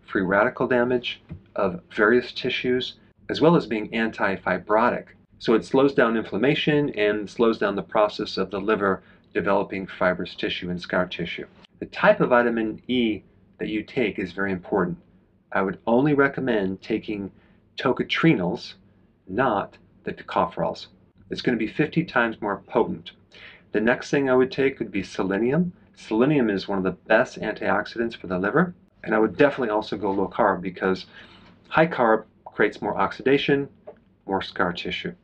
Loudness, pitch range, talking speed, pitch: -24 LUFS, 100-130 Hz, 160 wpm, 115 Hz